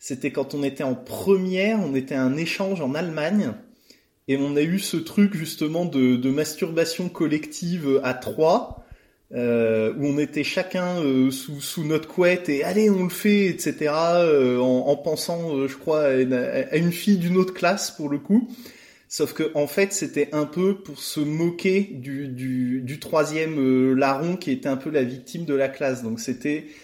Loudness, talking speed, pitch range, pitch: -23 LUFS, 195 wpm, 135-180 Hz, 150 Hz